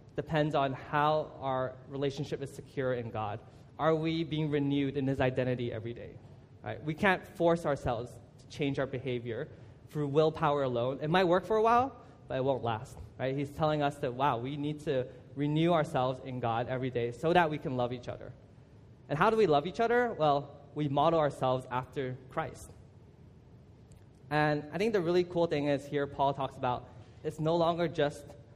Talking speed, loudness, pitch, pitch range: 190 wpm, -31 LUFS, 140 Hz, 125-150 Hz